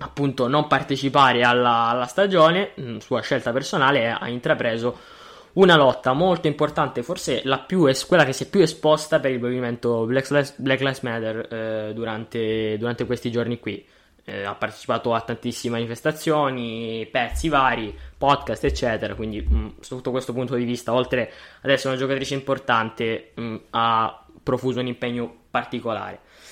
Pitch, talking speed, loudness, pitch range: 125 Hz, 150 wpm, -22 LUFS, 115-135 Hz